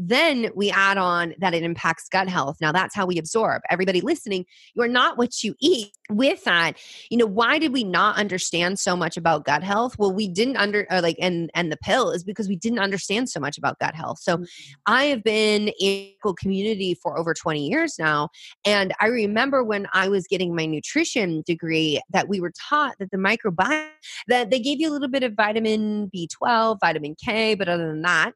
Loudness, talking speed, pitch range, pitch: -22 LUFS, 215 wpm, 175-230 Hz, 200 Hz